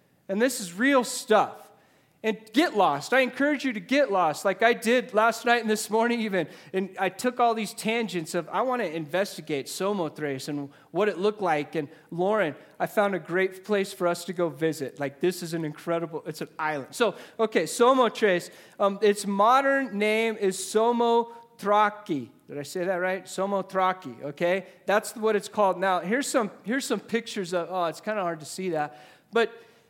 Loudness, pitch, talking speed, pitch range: -26 LUFS, 200 Hz, 195 wpm, 175-230 Hz